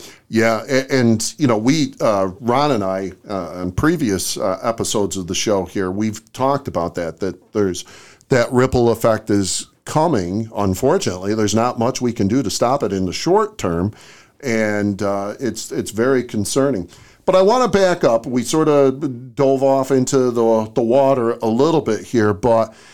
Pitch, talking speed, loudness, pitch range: 115 Hz, 185 wpm, -18 LUFS, 100-130 Hz